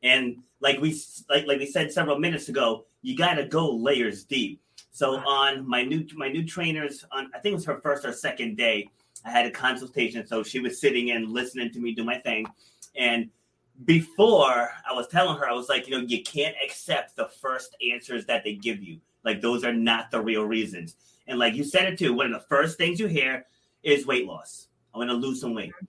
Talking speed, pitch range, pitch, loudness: 225 wpm, 120-150 Hz, 130 Hz, -25 LUFS